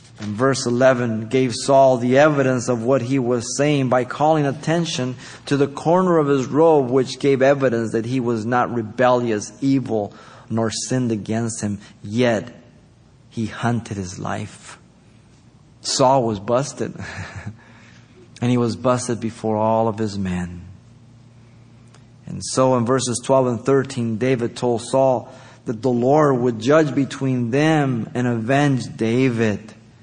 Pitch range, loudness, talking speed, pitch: 115-135 Hz, -19 LUFS, 140 wpm, 125 Hz